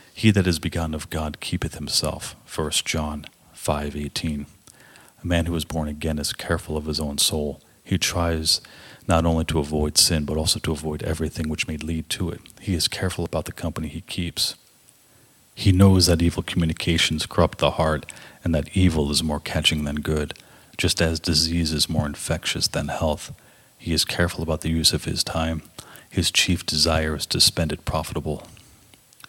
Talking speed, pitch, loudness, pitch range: 185 wpm, 80 Hz, -23 LUFS, 75-85 Hz